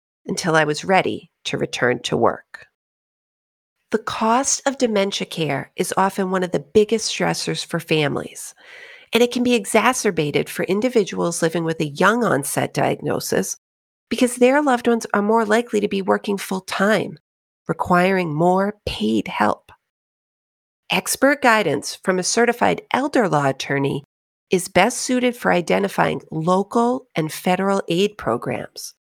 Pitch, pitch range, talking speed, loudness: 195 Hz, 170-235 Hz, 140 wpm, -20 LUFS